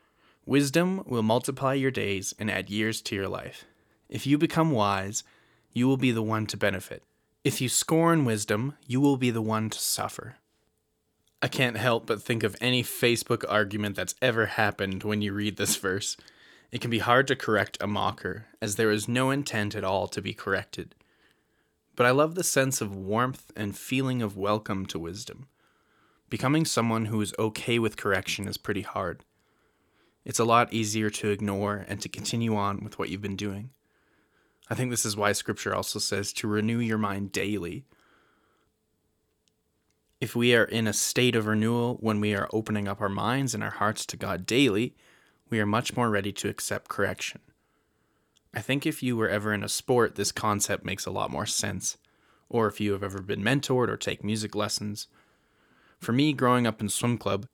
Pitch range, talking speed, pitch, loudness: 105-125 Hz, 190 wpm, 110 Hz, -27 LUFS